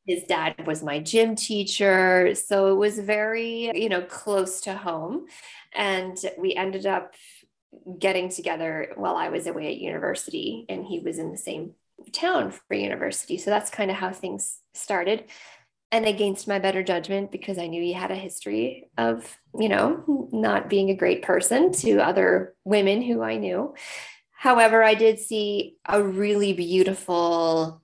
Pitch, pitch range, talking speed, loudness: 195 Hz, 180-220 Hz, 165 wpm, -24 LUFS